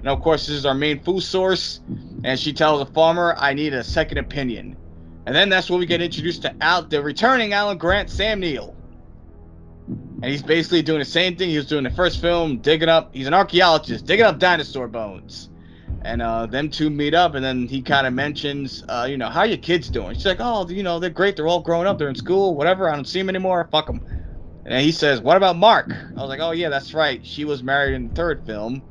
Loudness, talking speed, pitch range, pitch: -20 LUFS, 250 wpm, 130-175 Hz, 150 Hz